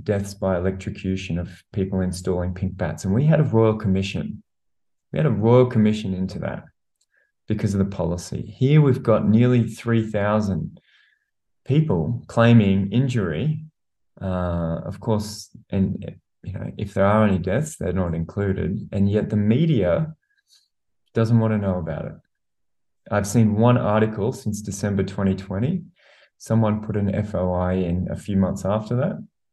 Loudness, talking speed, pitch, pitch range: -22 LUFS, 150 wpm, 105 Hz, 95-115 Hz